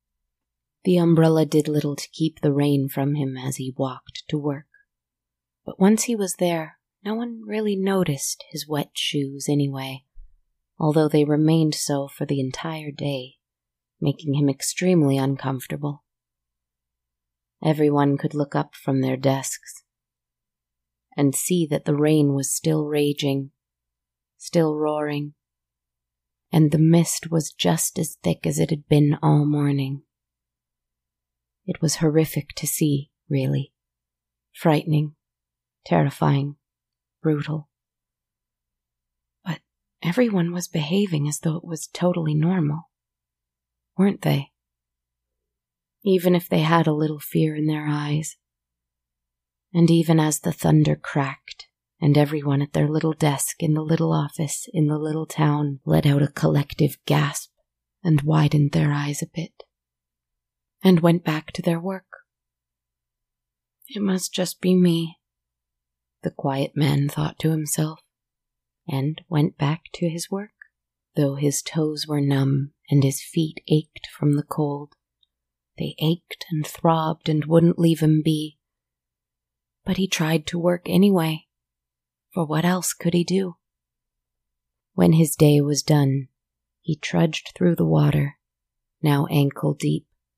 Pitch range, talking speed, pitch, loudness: 125-160 Hz, 135 wpm, 145 Hz, -22 LUFS